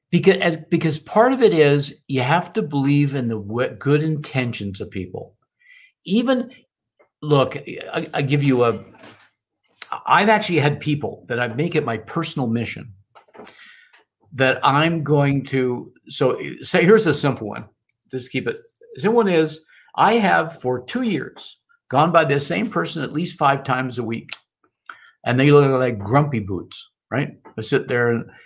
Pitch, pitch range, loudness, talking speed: 145 Hz, 125-170 Hz, -20 LUFS, 165 wpm